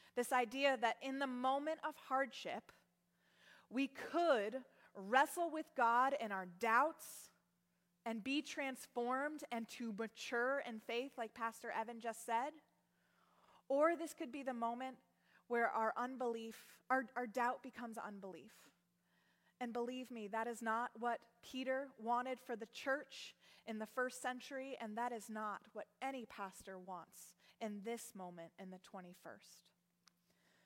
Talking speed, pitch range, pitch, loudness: 145 wpm, 225-265 Hz, 240 Hz, -42 LUFS